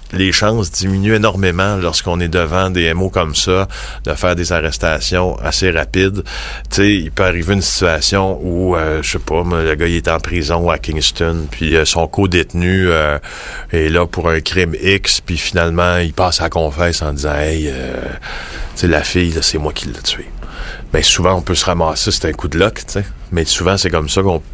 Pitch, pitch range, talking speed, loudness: 85 Hz, 80-95 Hz, 205 wpm, -15 LUFS